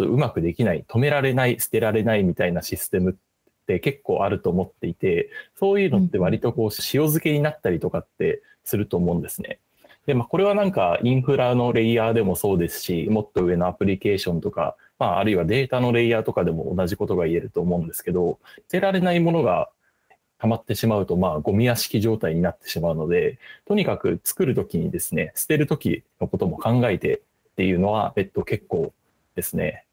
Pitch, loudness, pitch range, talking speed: 120 Hz, -23 LUFS, 105-165 Hz, 440 characters per minute